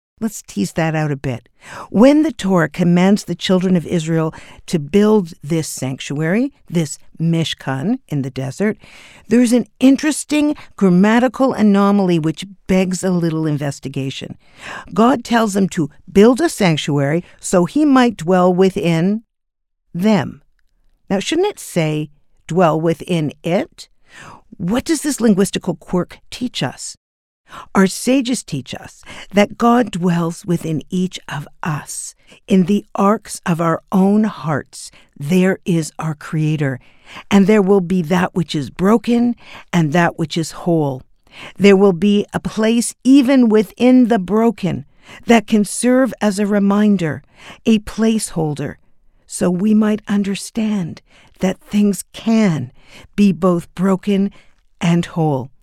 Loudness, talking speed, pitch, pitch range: -16 LUFS, 135 wpm, 190 Hz, 165-215 Hz